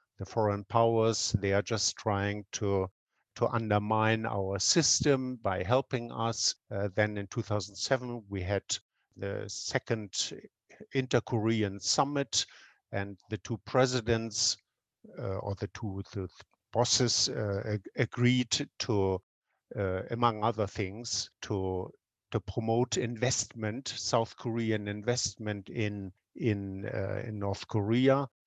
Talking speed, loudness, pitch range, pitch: 120 wpm, -31 LUFS, 100-120 Hz, 110 Hz